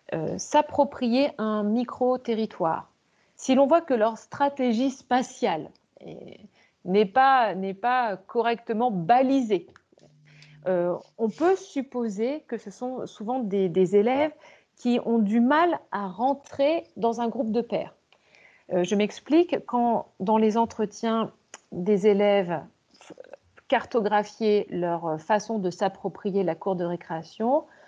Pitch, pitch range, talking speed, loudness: 230 Hz, 200-260 Hz, 125 wpm, -25 LUFS